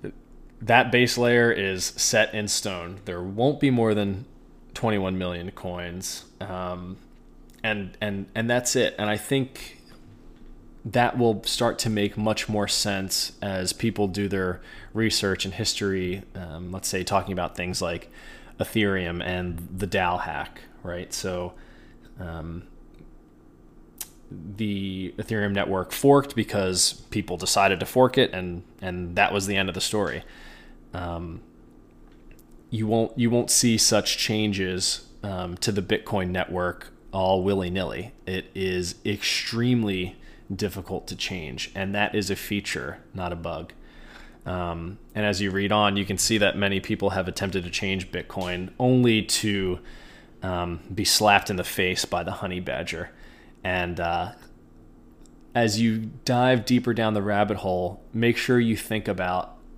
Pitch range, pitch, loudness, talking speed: 90-110 Hz, 95 Hz, -25 LUFS, 150 wpm